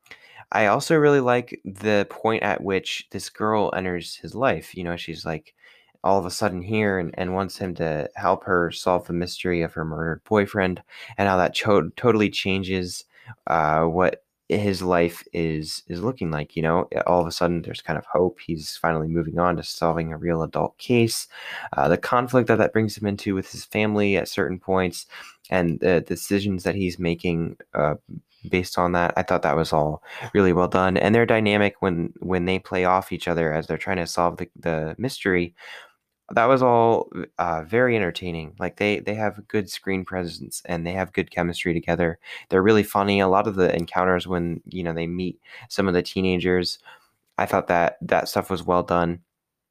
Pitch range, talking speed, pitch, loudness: 85-100 Hz, 200 wpm, 90 Hz, -23 LUFS